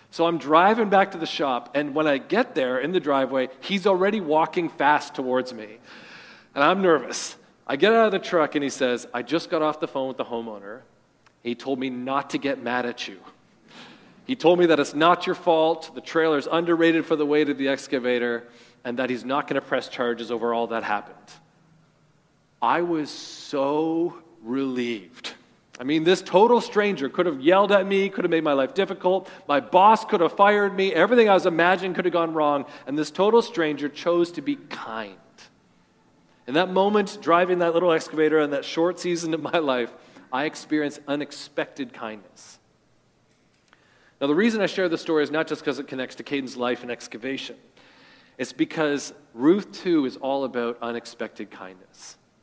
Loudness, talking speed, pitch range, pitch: -23 LUFS, 190 wpm, 135-180 Hz, 155 Hz